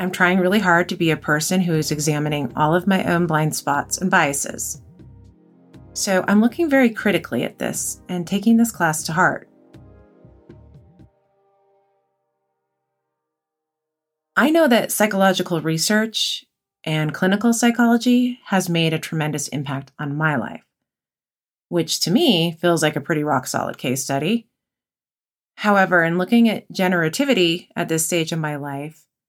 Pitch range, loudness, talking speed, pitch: 150-195 Hz, -19 LUFS, 145 wpm, 170 Hz